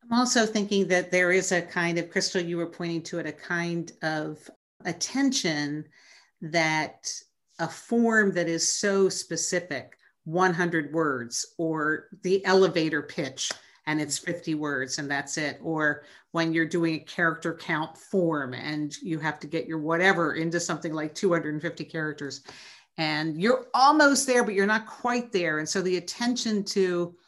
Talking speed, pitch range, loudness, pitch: 160 wpm, 155-190 Hz, -26 LUFS, 170 Hz